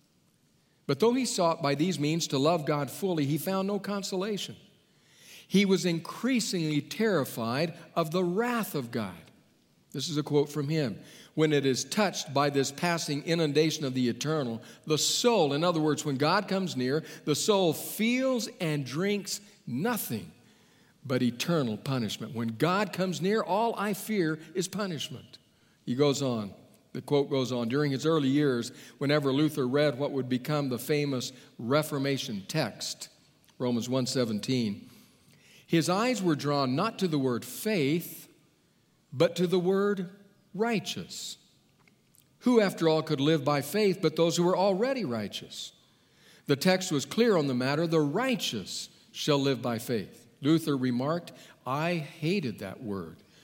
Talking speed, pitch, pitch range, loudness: 155 wpm, 155 Hz, 140-185 Hz, -29 LUFS